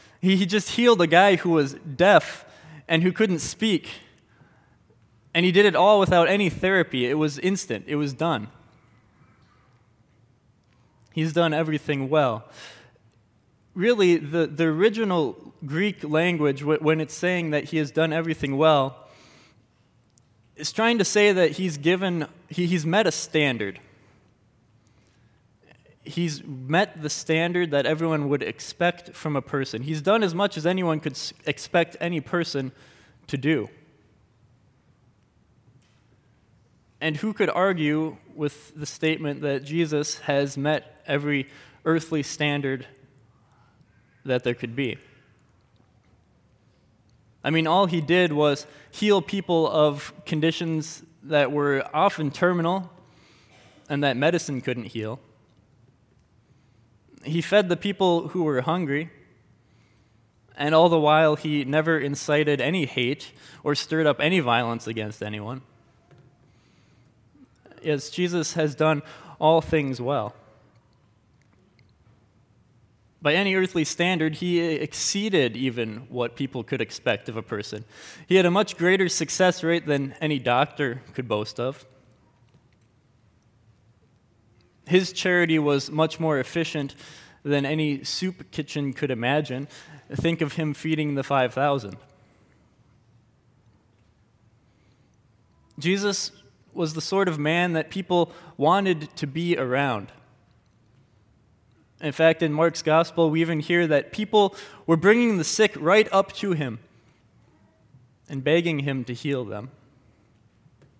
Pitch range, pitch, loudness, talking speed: 120-165 Hz, 145 Hz, -23 LUFS, 125 wpm